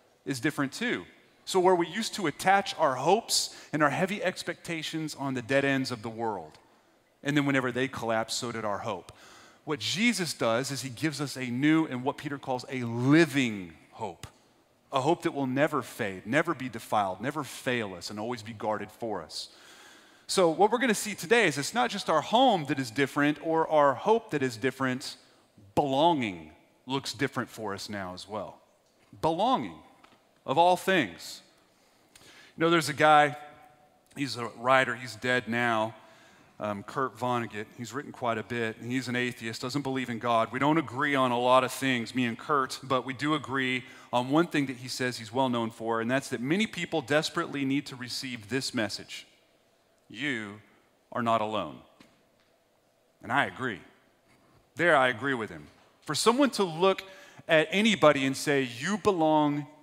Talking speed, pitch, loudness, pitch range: 185 wpm, 135 Hz, -28 LUFS, 120-155 Hz